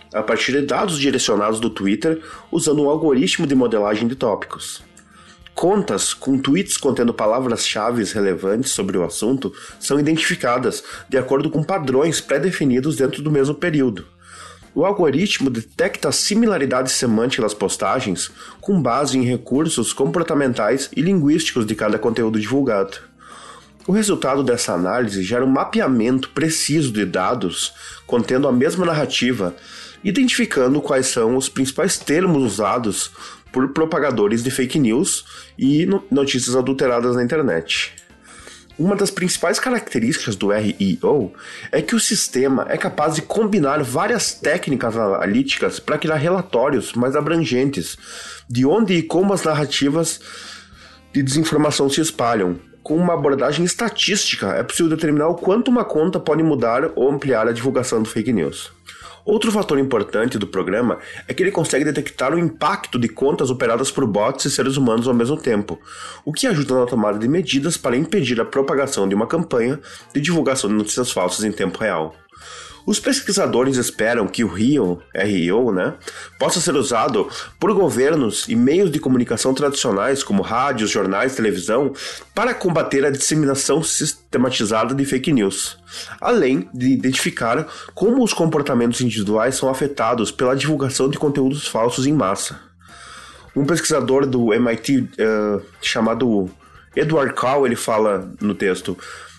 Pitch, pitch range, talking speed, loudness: 135 Hz, 120-160 Hz, 145 wpm, -19 LUFS